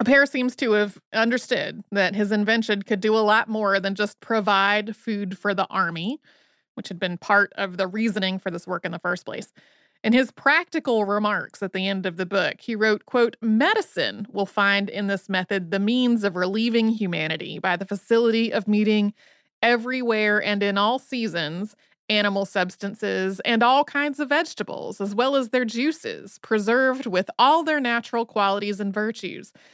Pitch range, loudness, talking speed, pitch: 195-235 Hz, -23 LUFS, 180 wpm, 210 Hz